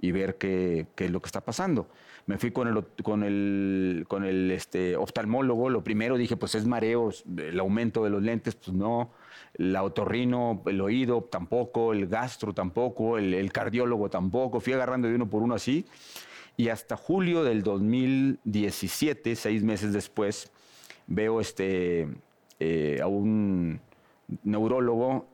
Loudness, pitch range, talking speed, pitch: -28 LUFS, 95-120 Hz, 155 wpm, 110 Hz